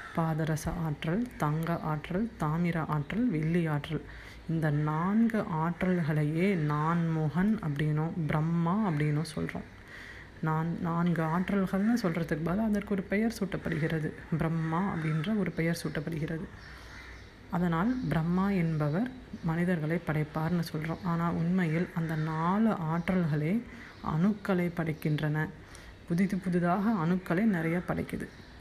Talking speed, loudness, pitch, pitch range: 105 wpm, -31 LUFS, 165 Hz, 155-185 Hz